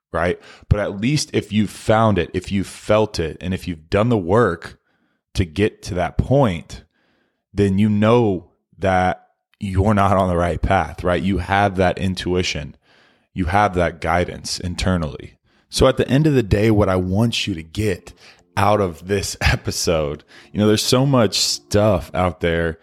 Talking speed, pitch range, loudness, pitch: 180 wpm, 90-105 Hz, -19 LUFS, 95 Hz